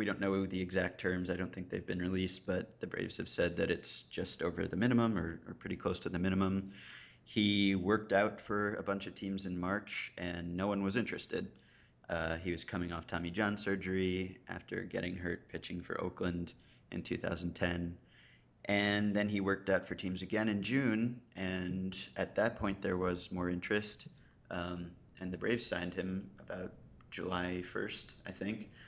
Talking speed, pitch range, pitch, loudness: 185 wpm, 90-100 Hz, 95 Hz, -37 LUFS